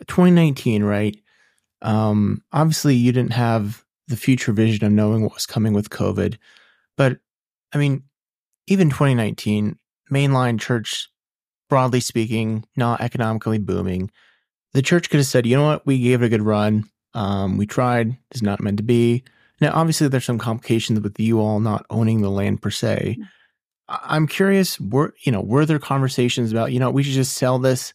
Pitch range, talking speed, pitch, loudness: 110-135 Hz, 175 wpm, 120 Hz, -20 LUFS